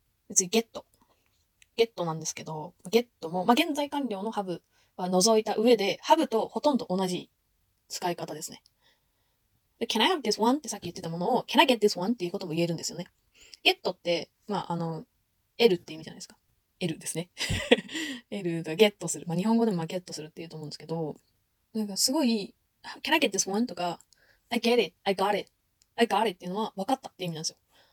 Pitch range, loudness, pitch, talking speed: 170-230 Hz, -28 LUFS, 195 Hz, 470 characters per minute